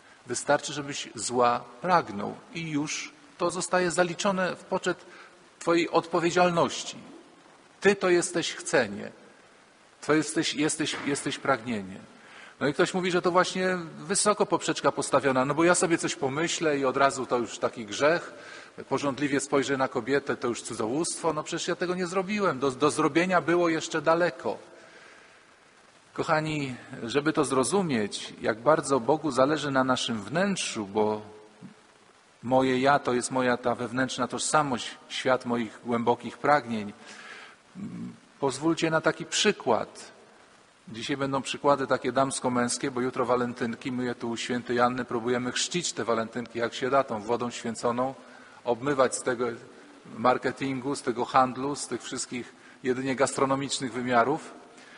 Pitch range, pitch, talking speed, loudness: 125-165 Hz, 140 Hz, 140 wpm, -27 LUFS